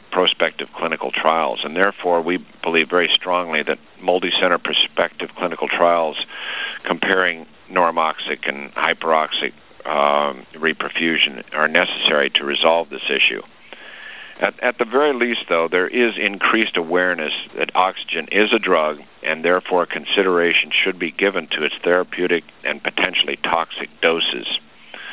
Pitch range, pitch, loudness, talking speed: 75-90 Hz, 85 Hz, -18 LUFS, 130 wpm